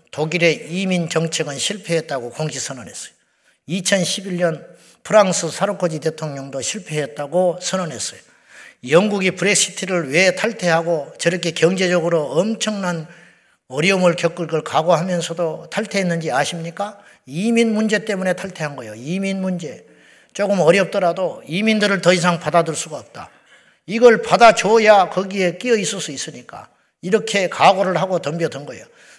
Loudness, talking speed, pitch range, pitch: -18 LUFS, 325 characters per minute, 165-195 Hz, 175 Hz